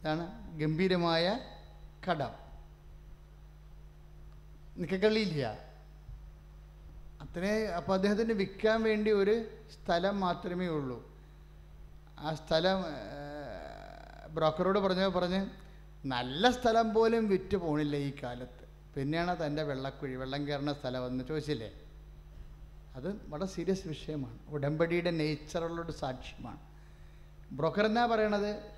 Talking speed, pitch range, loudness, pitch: 90 wpm, 125-190 Hz, -33 LUFS, 155 Hz